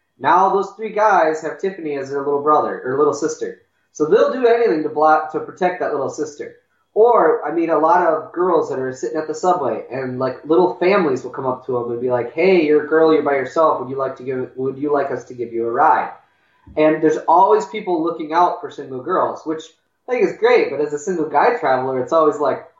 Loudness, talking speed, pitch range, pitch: -18 LUFS, 245 wpm, 140-195 Hz, 155 Hz